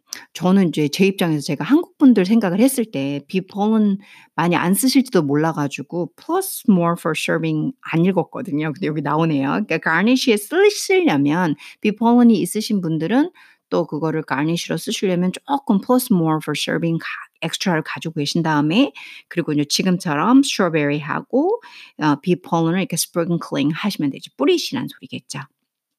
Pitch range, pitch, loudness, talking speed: 155-230 Hz, 175 Hz, -19 LUFS, 360 characters per minute